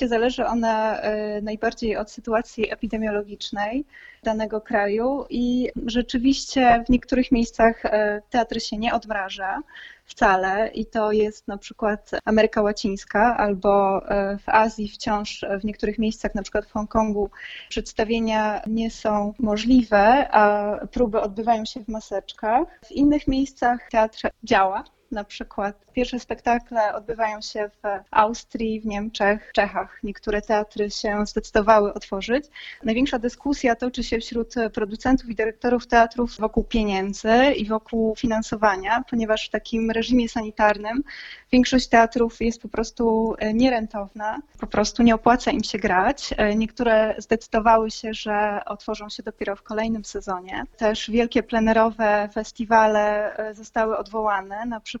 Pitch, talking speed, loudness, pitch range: 220 Hz, 130 wpm, -22 LUFS, 210-235 Hz